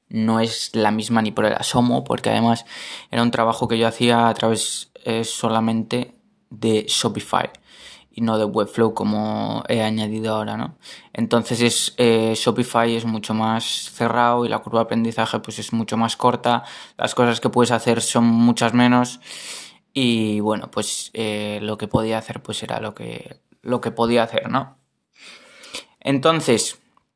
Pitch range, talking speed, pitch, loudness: 110-120 Hz, 165 wpm, 115 Hz, -20 LUFS